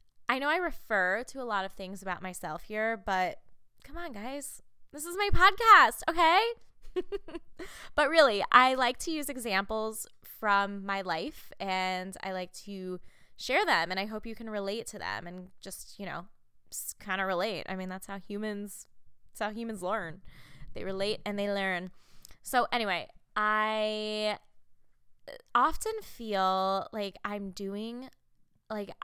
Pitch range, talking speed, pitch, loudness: 190-245 Hz, 155 wpm, 205 Hz, -30 LUFS